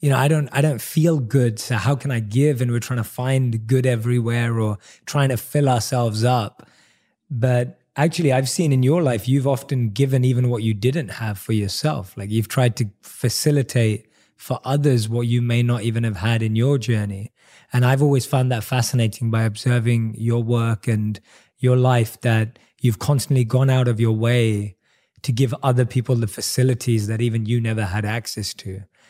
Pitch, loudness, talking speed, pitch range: 120 Hz, -20 LUFS, 195 wpm, 115-130 Hz